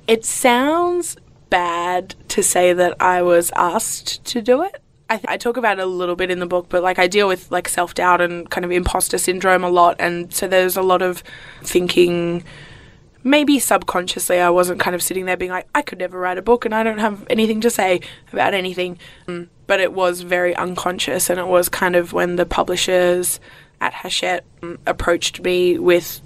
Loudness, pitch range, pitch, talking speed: -18 LUFS, 175-190 Hz, 180 Hz, 200 wpm